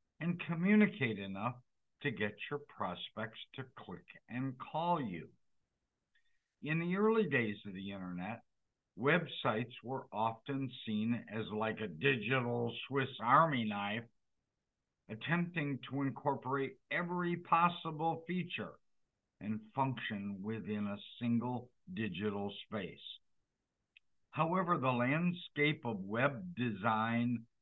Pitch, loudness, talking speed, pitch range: 125 Hz, -37 LUFS, 105 wpm, 110-160 Hz